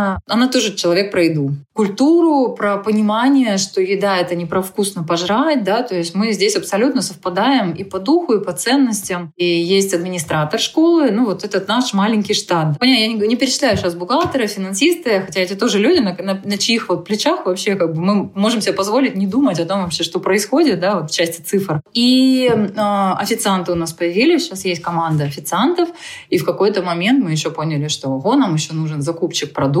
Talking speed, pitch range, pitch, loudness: 195 wpm, 175-245 Hz, 200 Hz, -16 LUFS